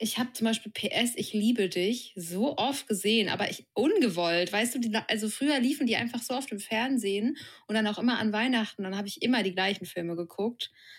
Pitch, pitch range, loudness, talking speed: 220 Hz, 200-245 Hz, -29 LUFS, 220 wpm